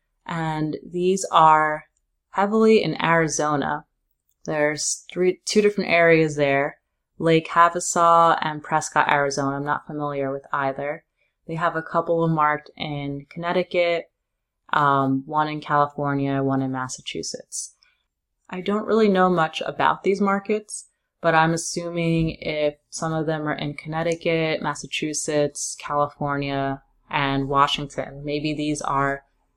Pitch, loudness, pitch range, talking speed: 155 Hz, -22 LUFS, 145-170 Hz, 125 wpm